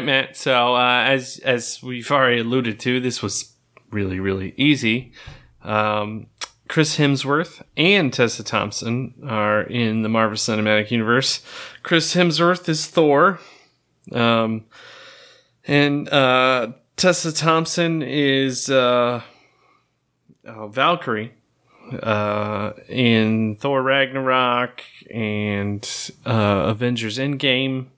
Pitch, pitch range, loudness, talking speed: 125 Hz, 110-135 Hz, -19 LUFS, 100 wpm